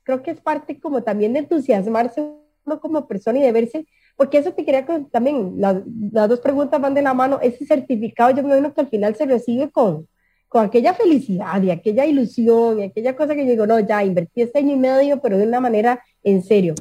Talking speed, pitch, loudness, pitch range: 230 wpm, 255 Hz, -18 LUFS, 220-290 Hz